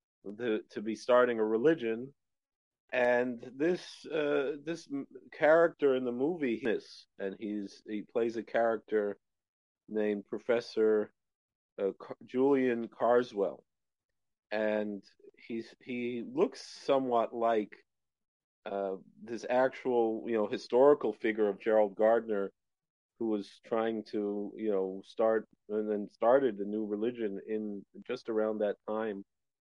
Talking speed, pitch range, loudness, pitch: 120 wpm, 105-125 Hz, -32 LUFS, 110 Hz